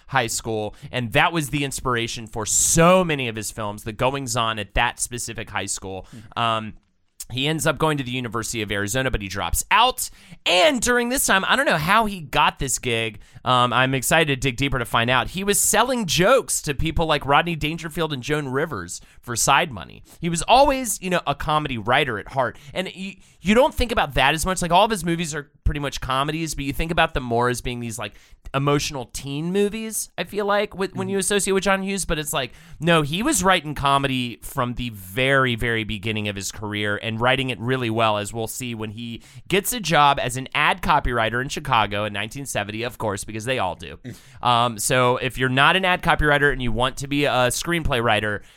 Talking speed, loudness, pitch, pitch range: 225 wpm, -21 LUFS, 135 Hz, 115-165 Hz